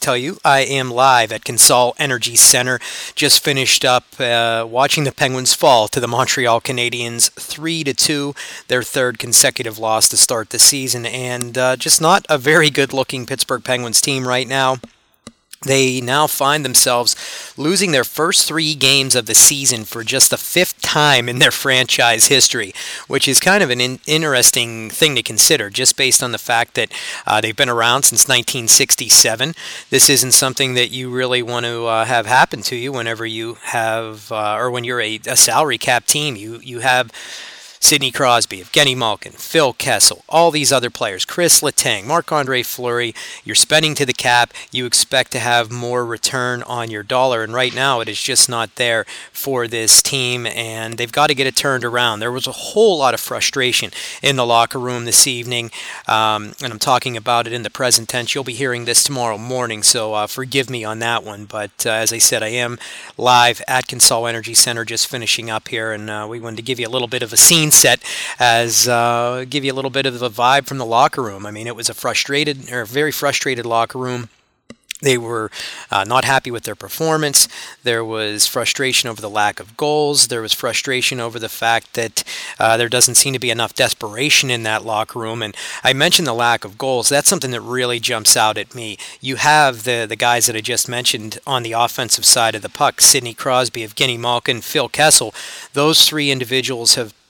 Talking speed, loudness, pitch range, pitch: 205 wpm, -14 LUFS, 115-135 Hz, 125 Hz